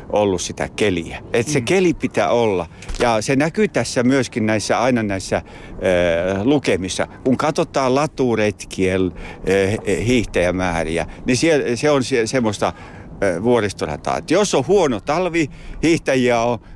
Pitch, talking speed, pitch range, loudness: 120 Hz, 125 wpm, 95-140 Hz, -19 LUFS